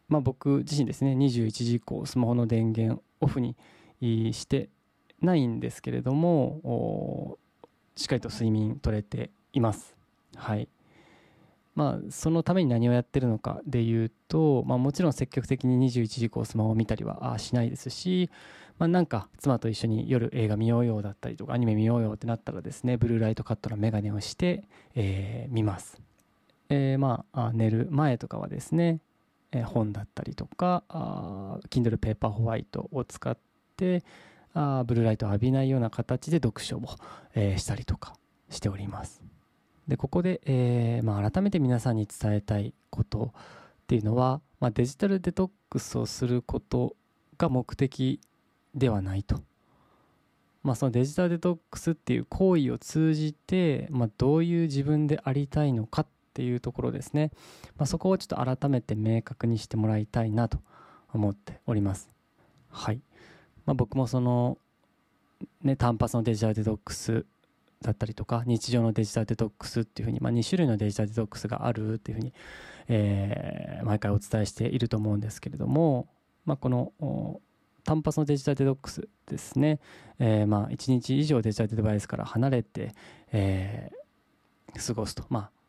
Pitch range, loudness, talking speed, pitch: 110-145 Hz, -29 LUFS, 340 characters per minute, 120 Hz